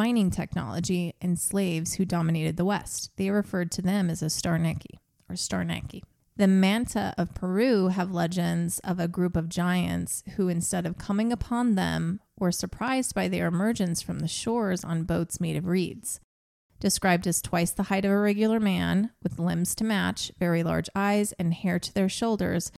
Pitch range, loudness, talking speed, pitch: 170-200 Hz, -27 LUFS, 180 wpm, 180 Hz